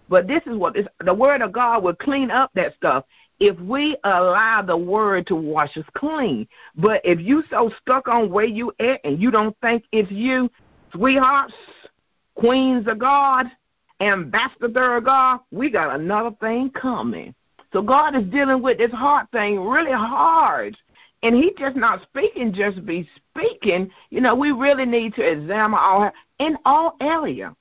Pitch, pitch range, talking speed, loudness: 235 Hz, 210-265 Hz, 170 wpm, -19 LUFS